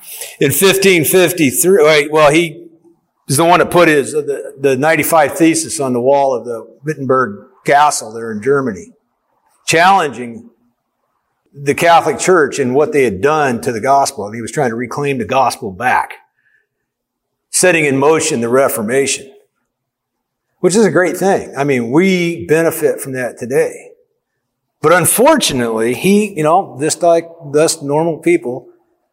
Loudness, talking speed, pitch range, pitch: -13 LUFS, 155 wpm, 140-190 Hz, 160 Hz